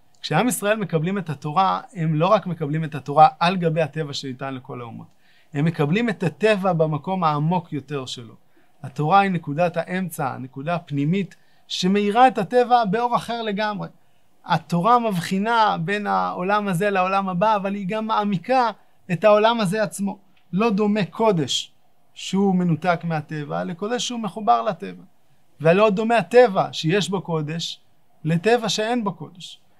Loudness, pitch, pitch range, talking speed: -21 LUFS, 185 Hz, 160-215 Hz, 145 wpm